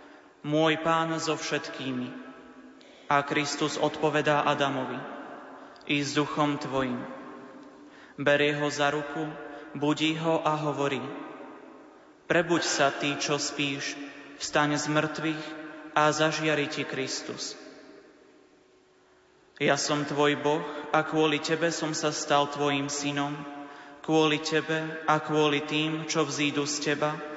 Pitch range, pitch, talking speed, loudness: 145-155 Hz, 150 Hz, 110 wpm, -27 LUFS